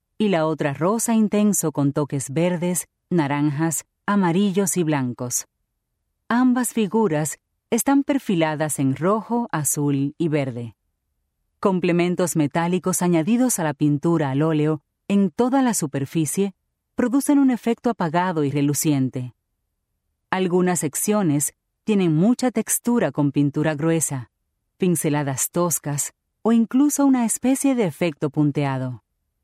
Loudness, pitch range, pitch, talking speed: -21 LUFS, 145-210 Hz, 165 Hz, 115 wpm